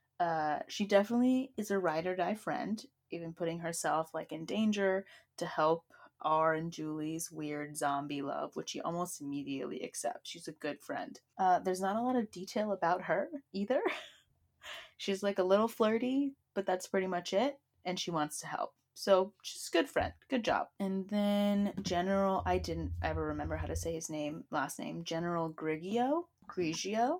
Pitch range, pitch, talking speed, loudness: 155-205 Hz, 180 Hz, 180 wpm, -35 LUFS